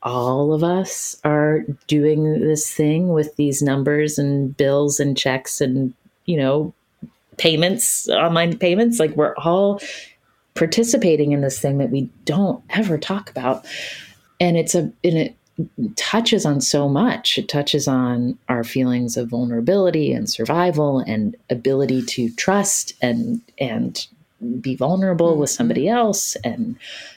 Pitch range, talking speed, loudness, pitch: 140-185 Hz, 140 wpm, -19 LUFS, 155 Hz